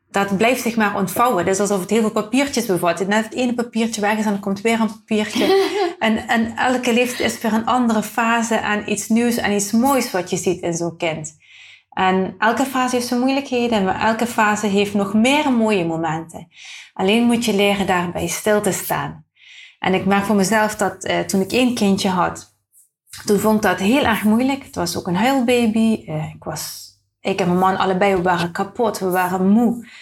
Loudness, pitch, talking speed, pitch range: -18 LUFS, 210 Hz, 210 wpm, 190-230 Hz